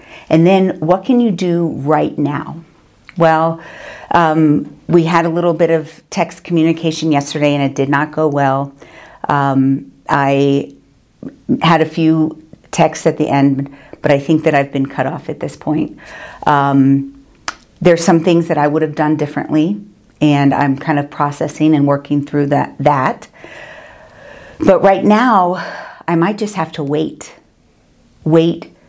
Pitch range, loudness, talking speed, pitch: 145-170 Hz, -14 LUFS, 155 wpm, 155 Hz